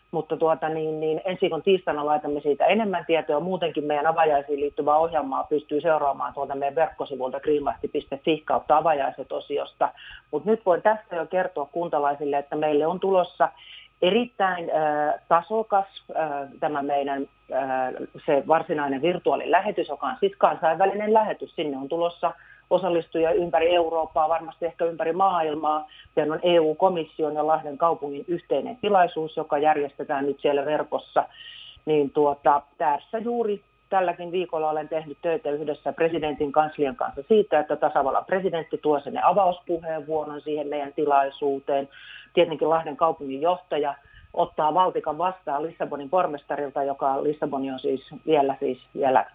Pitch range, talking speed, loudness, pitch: 145-175 Hz, 135 wpm, -25 LUFS, 155 Hz